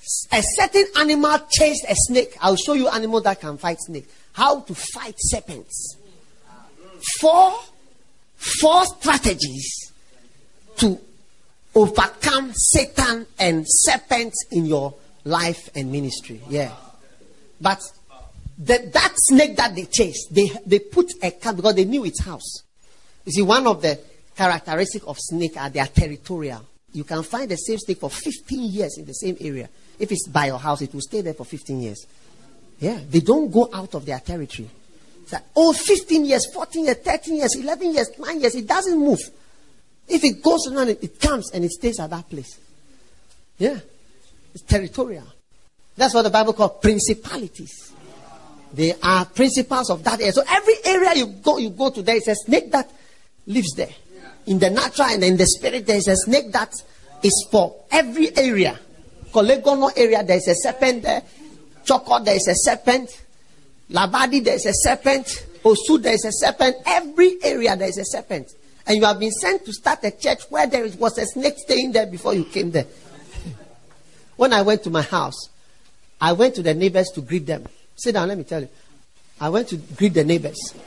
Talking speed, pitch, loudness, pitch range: 180 wpm, 215 Hz, -19 LUFS, 170-265 Hz